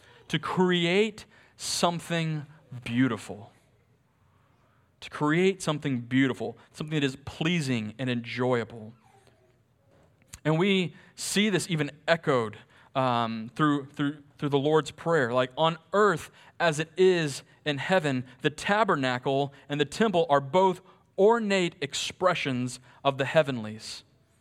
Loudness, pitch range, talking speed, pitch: -27 LUFS, 125-170 Hz, 115 wpm, 145 Hz